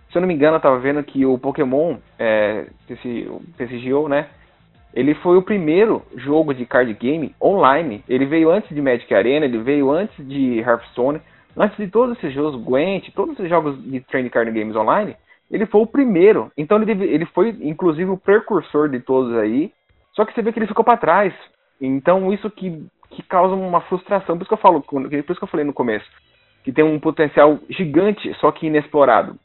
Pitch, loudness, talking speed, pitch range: 155 Hz, -18 LUFS, 205 wpm, 135-190 Hz